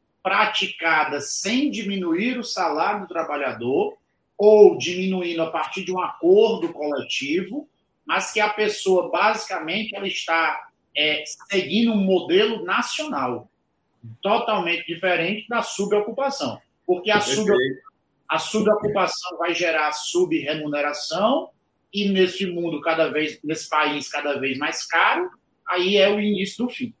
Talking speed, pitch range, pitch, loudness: 125 wpm, 160-215 Hz, 190 Hz, -21 LUFS